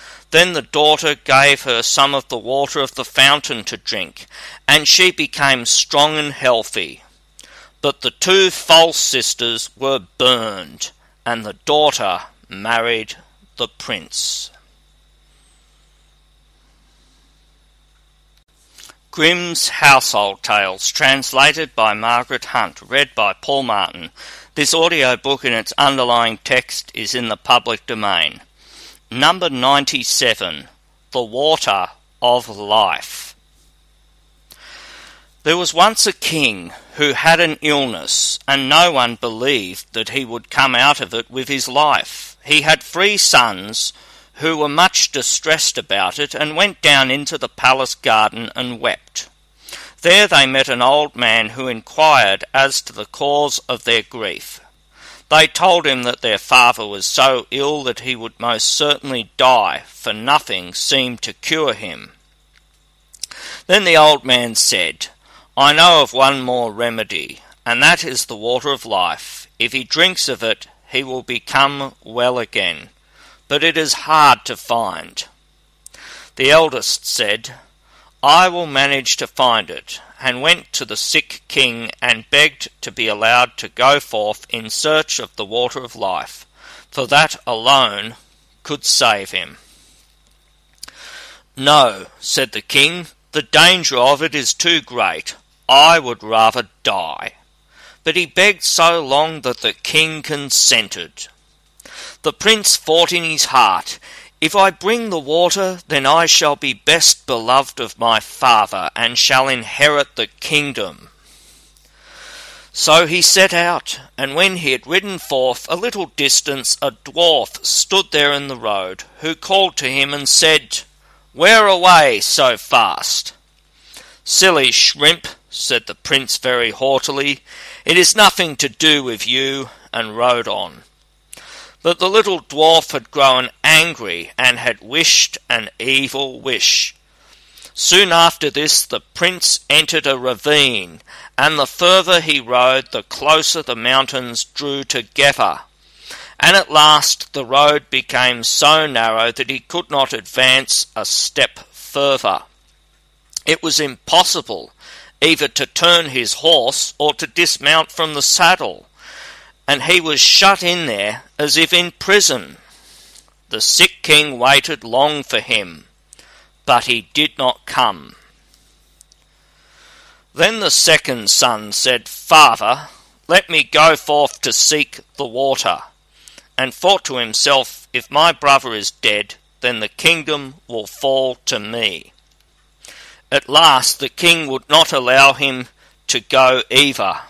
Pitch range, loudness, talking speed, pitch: 125-160 Hz, -13 LUFS, 140 wpm, 140 Hz